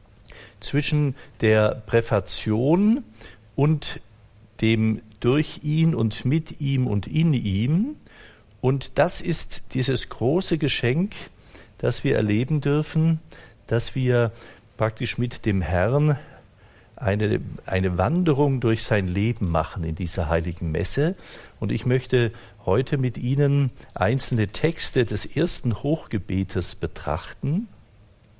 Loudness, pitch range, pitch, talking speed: -23 LUFS, 105-150 Hz, 120 Hz, 110 wpm